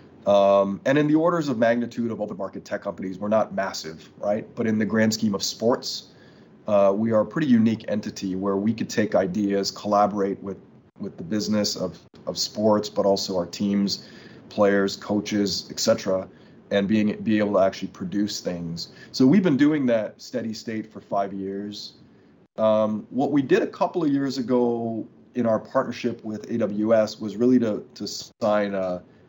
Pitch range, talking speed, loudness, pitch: 100-115 Hz, 180 wpm, -24 LUFS, 105 Hz